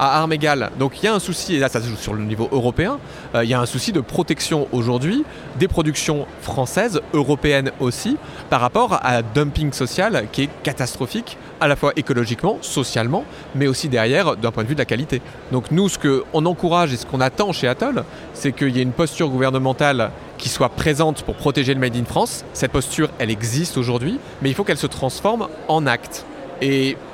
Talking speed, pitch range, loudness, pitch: 215 wpm, 125-155 Hz, -20 LUFS, 140 Hz